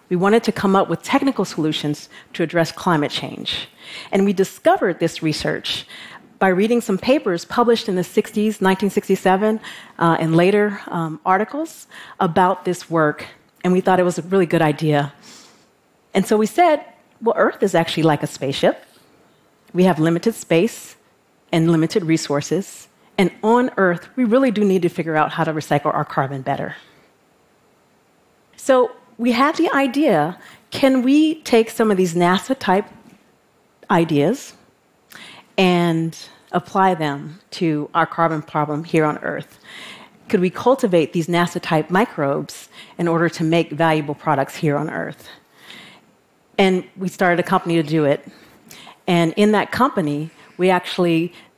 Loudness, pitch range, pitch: -19 LUFS, 160-210 Hz, 180 Hz